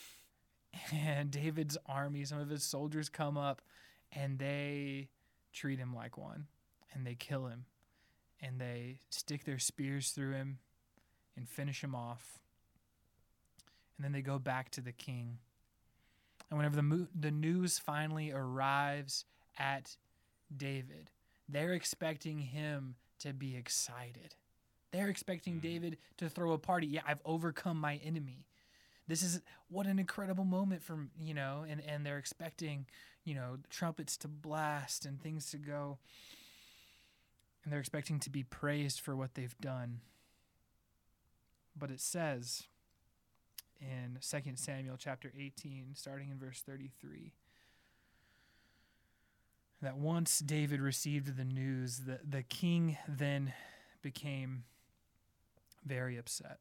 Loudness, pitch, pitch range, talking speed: -40 LUFS, 140 Hz, 125-150 Hz, 130 wpm